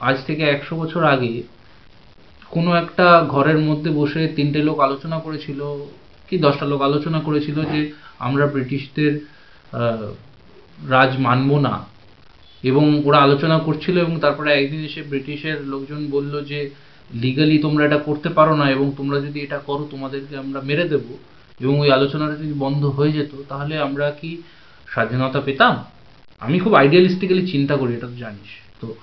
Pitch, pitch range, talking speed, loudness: 145 Hz, 135-150 Hz, 150 wpm, -19 LUFS